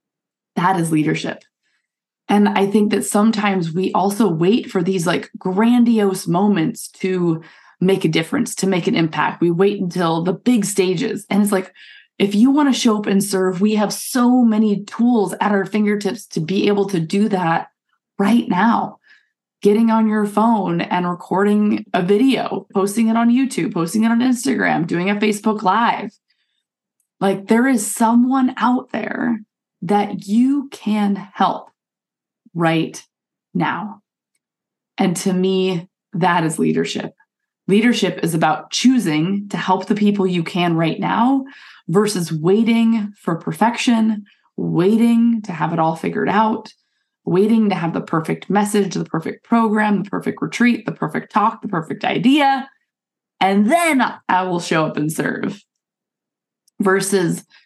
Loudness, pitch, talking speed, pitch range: -18 LUFS, 205 Hz, 150 wpm, 185-230 Hz